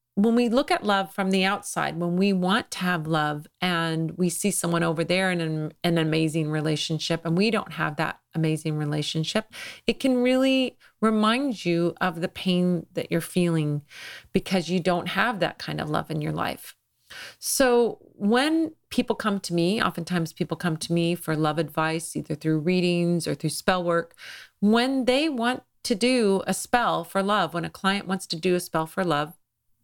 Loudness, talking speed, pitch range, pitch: -25 LUFS, 185 wpm, 165-210 Hz, 180 Hz